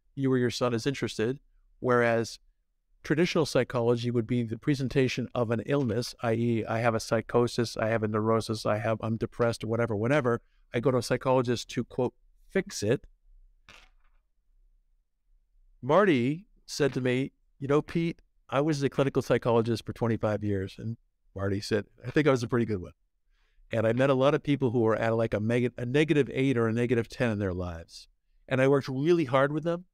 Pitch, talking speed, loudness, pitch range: 120 Hz, 190 wpm, -28 LUFS, 110-135 Hz